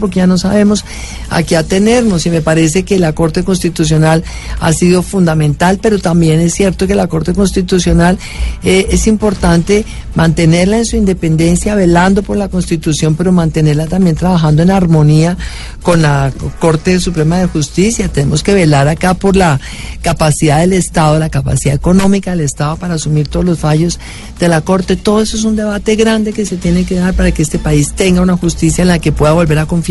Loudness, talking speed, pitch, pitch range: -11 LUFS, 190 wpm, 175 Hz, 160-190 Hz